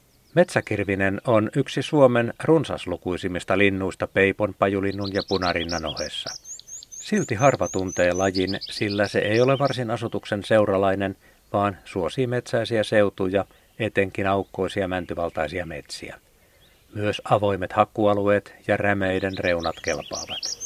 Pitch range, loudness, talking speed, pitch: 95-110 Hz, -23 LUFS, 110 wpm, 100 Hz